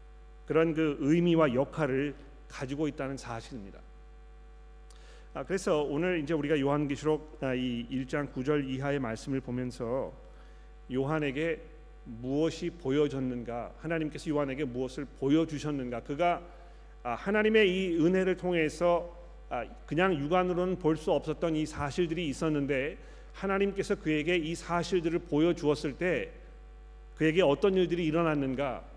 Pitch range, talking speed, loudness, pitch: 135-170 Hz, 295 characters per minute, -30 LUFS, 150 Hz